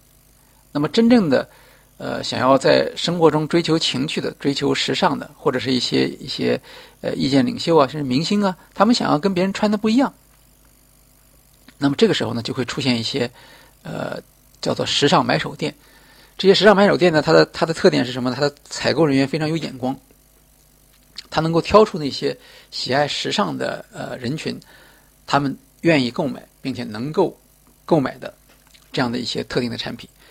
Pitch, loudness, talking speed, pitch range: 140 Hz, -19 LUFS, 275 characters per minute, 130-180 Hz